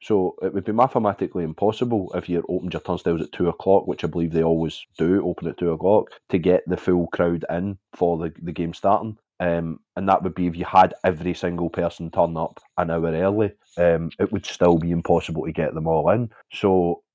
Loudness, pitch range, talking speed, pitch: -22 LUFS, 85-95 Hz, 220 wpm, 85 Hz